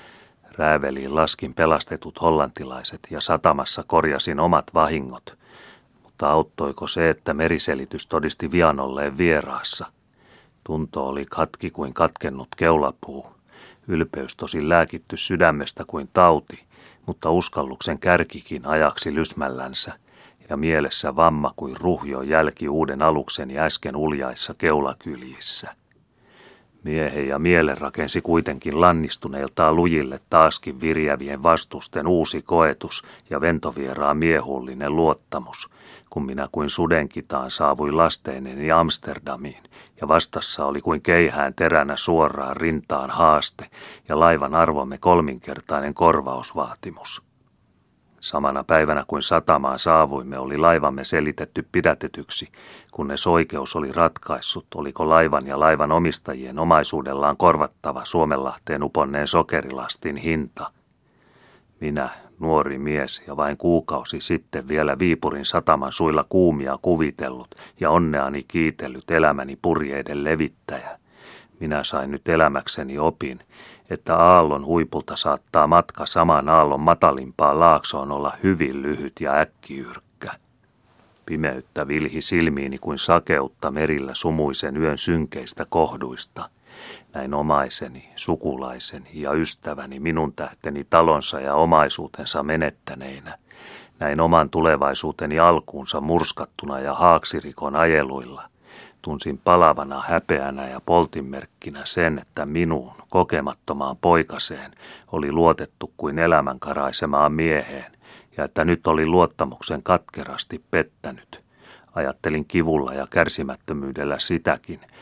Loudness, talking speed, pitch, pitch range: -21 LUFS, 105 wpm, 75 Hz, 70-80 Hz